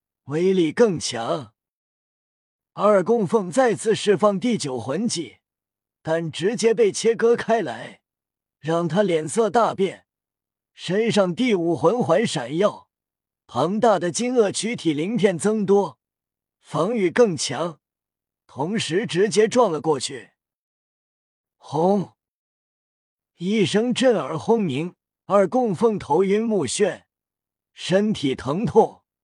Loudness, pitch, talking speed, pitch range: -21 LUFS, 195 Hz, 160 characters per minute, 160-225 Hz